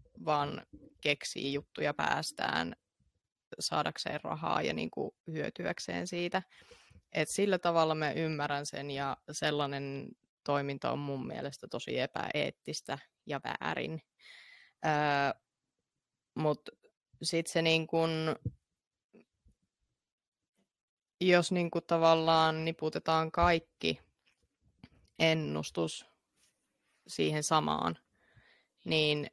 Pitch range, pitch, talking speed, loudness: 140-165 Hz, 150 Hz, 80 wpm, -33 LUFS